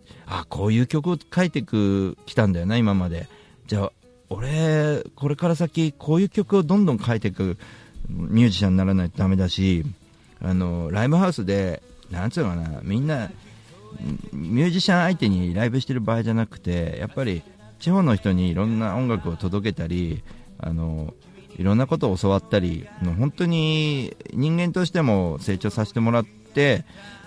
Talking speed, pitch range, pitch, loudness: 345 characters per minute, 95-150 Hz, 110 Hz, -23 LUFS